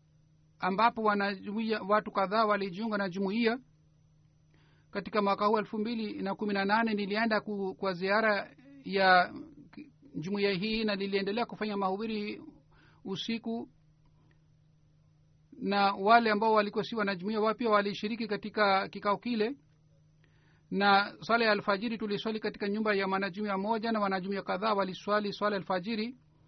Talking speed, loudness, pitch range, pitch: 120 wpm, -30 LUFS, 190-215 Hz, 205 Hz